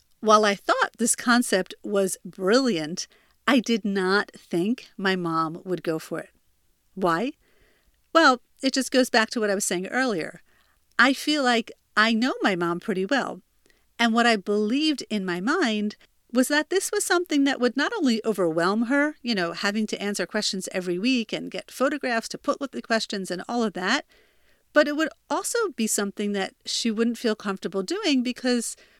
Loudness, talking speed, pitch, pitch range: -24 LUFS, 185 wpm, 225 Hz, 195-265 Hz